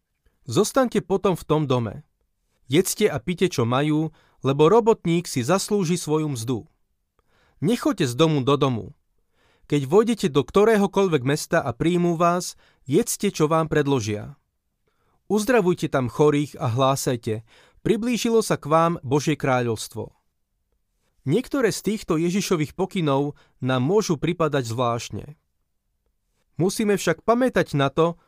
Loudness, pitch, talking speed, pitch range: -22 LUFS, 155 Hz, 125 wpm, 135-190 Hz